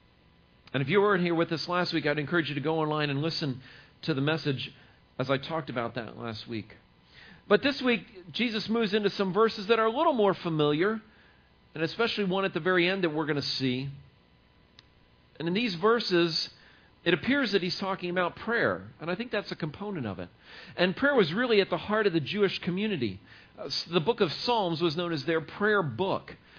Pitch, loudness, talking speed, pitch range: 170 Hz, -28 LUFS, 215 wpm, 140-200 Hz